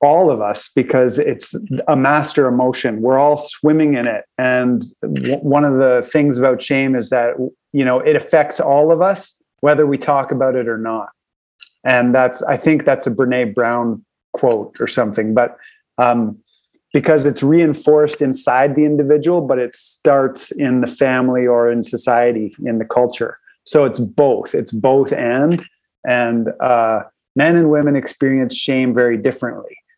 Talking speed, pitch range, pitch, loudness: 165 wpm, 125-150 Hz, 130 Hz, -15 LUFS